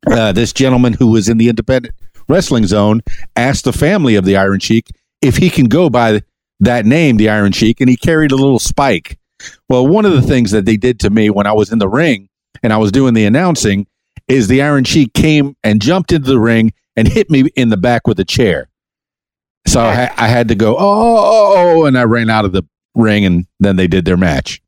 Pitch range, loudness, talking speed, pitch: 105-130 Hz, -11 LUFS, 230 wpm, 115 Hz